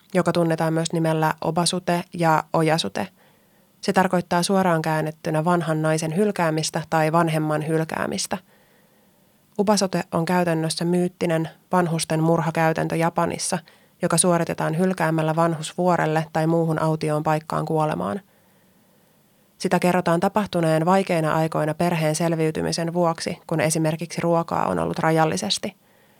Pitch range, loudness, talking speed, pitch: 160-180 Hz, -22 LUFS, 110 wpm, 170 Hz